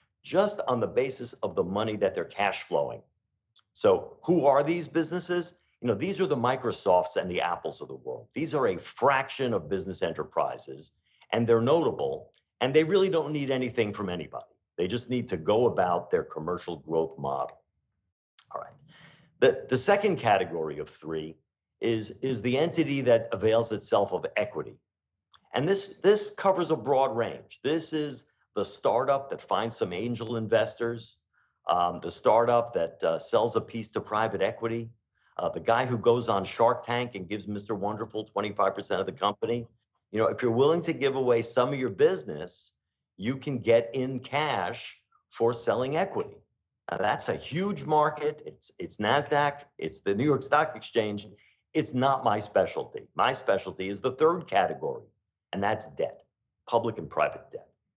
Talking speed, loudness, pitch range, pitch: 175 wpm, -28 LUFS, 110-155 Hz, 120 Hz